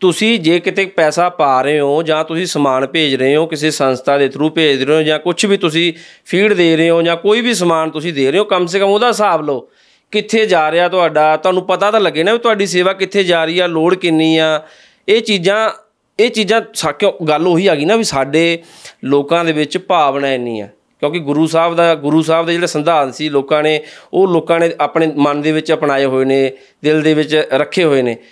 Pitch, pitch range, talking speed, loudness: 165 Hz, 150-185 Hz, 225 wpm, -13 LUFS